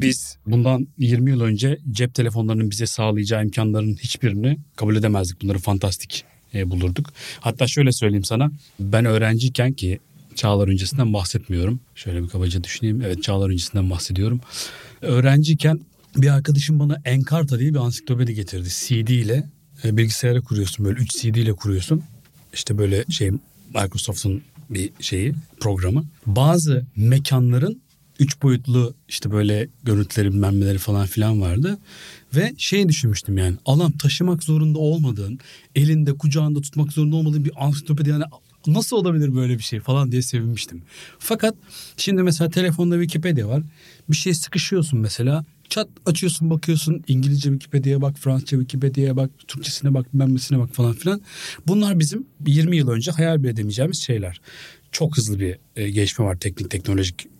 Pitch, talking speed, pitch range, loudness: 130 Hz, 140 wpm, 110-150 Hz, -21 LUFS